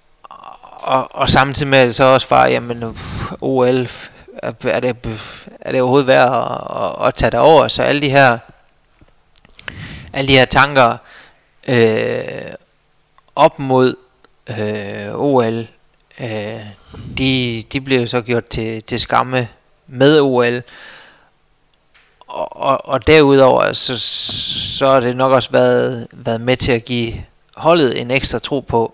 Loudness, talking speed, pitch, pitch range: -14 LUFS, 140 wpm, 125 Hz, 115-135 Hz